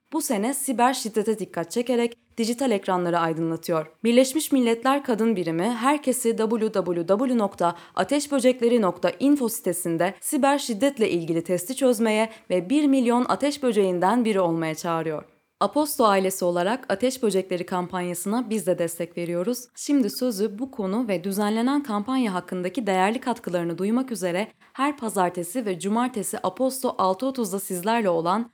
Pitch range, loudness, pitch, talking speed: 180-250 Hz, -24 LUFS, 220 Hz, 125 wpm